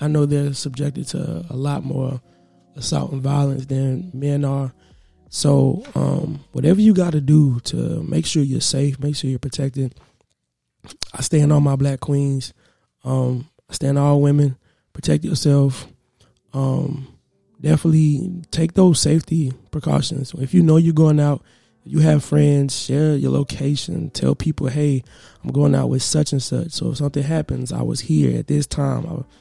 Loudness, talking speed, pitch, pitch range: -19 LUFS, 170 wpm, 140 Hz, 130-150 Hz